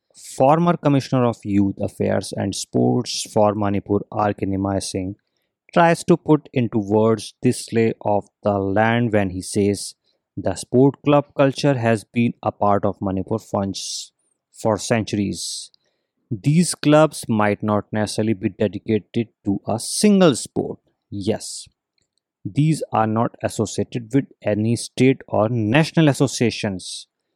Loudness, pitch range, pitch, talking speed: -20 LUFS, 100-130 Hz, 110 Hz, 130 wpm